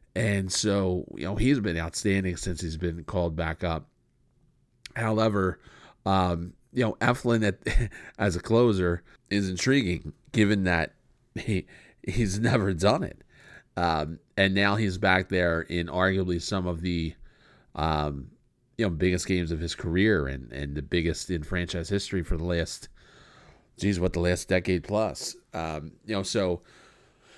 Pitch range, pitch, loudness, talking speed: 85-105 Hz, 90 Hz, -27 LUFS, 155 wpm